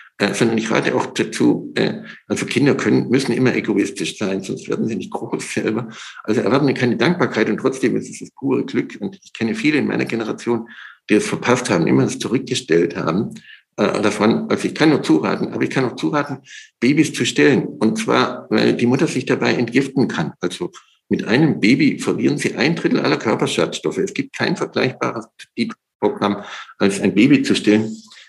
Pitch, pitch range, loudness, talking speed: 120 Hz, 110-130 Hz, -18 LUFS, 195 wpm